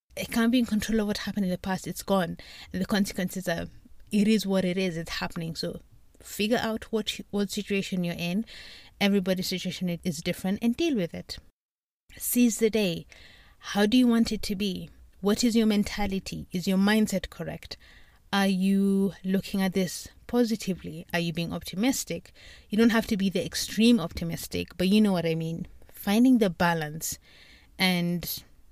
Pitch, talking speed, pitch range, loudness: 195 Hz, 180 wpm, 175-215 Hz, -27 LUFS